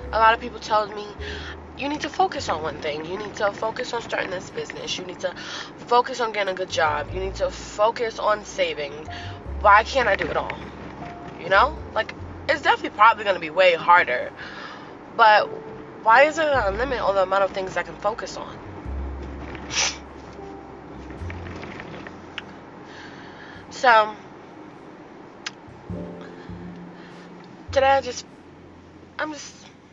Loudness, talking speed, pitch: -22 LUFS, 150 wpm, 200 Hz